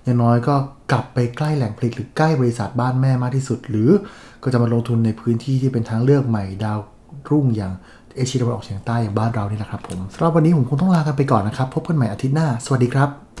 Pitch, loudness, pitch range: 125 Hz, -20 LUFS, 115-140 Hz